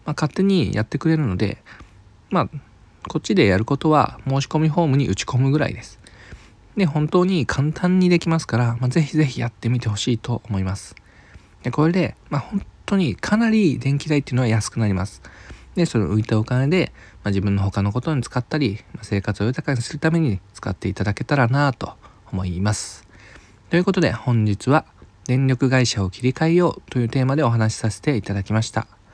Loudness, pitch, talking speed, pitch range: -21 LUFS, 120 Hz, 395 characters per minute, 105-150 Hz